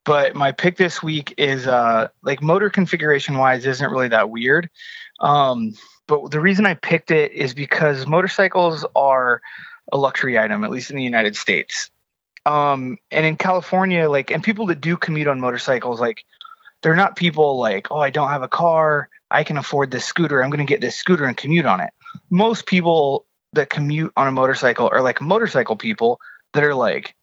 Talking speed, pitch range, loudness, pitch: 190 wpm, 135-180 Hz, -18 LUFS, 155 Hz